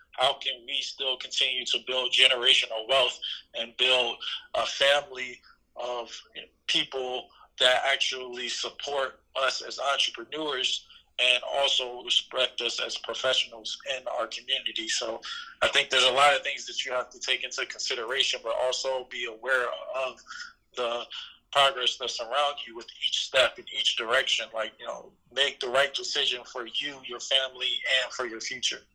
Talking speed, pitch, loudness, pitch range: 160 wpm, 130 Hz, -26 LUFS, 125-135 Hz